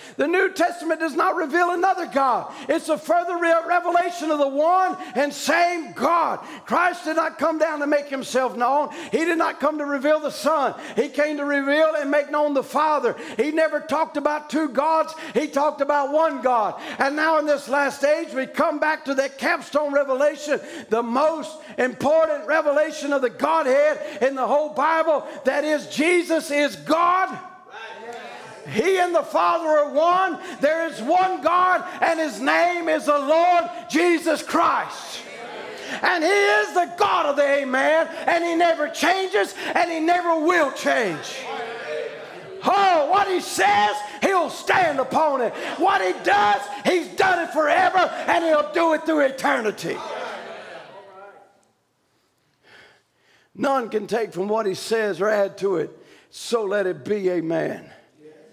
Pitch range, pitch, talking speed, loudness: 275-340 Hz, 305 Hz, 160 wpm, -21 LUFS